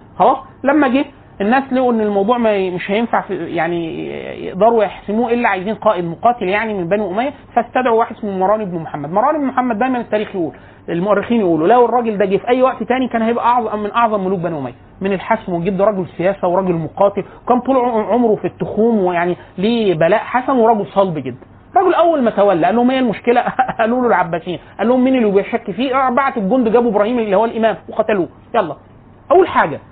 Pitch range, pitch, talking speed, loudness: 190-240 Hz, 215 Hz, 200 wpm, -16 LUFS